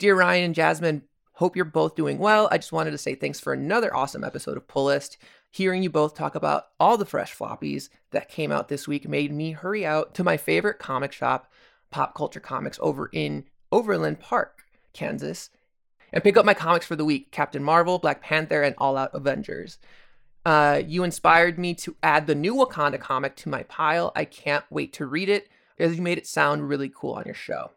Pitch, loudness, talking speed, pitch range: 155 Hz, -24 LUFS, 210 wpm, 145-180 Hz